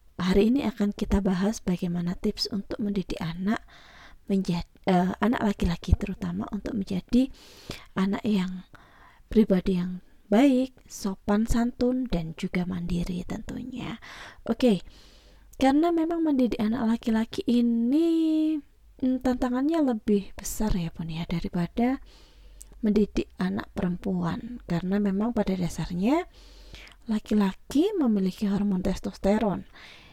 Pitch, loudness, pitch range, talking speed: 205 Hz, -27 LUFS, 185-240 Hz, 110 wpm